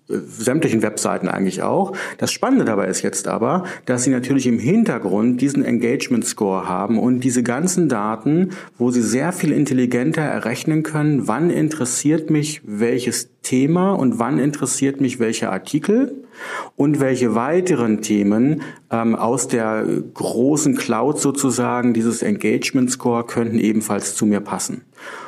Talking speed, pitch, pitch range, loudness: 140 wpm, 130 Hz, 115-150 Hz, -19 LUFS